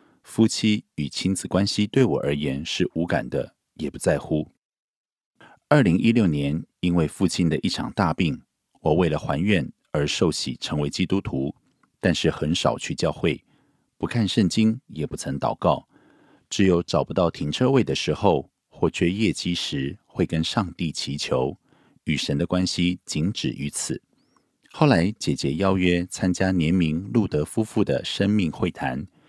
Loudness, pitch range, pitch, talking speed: -24 LUFS, 80-100 Hz, 90 Hz, 230 characters per minute